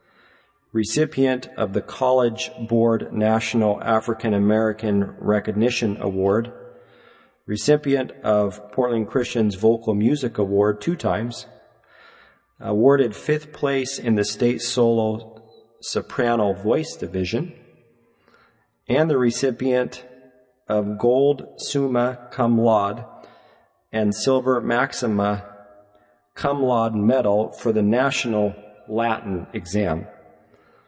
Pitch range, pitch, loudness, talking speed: 105-125 Hz, 115 Hz, -22 LUFS, 95 wpm